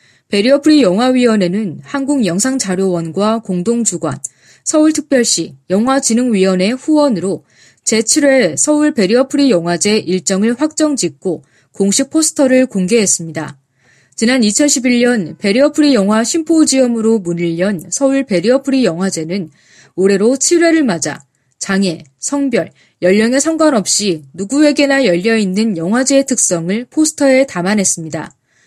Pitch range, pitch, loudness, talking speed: 180-270 Hz, 220 Hz, -13 LUFS, 300 characters per minute